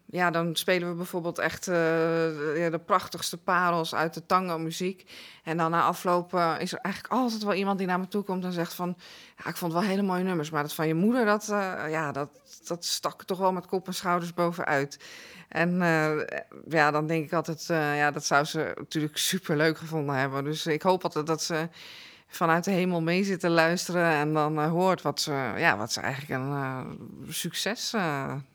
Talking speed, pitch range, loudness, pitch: 215 wpm, 155-180 Hz, -28 LUFS, 170 Hz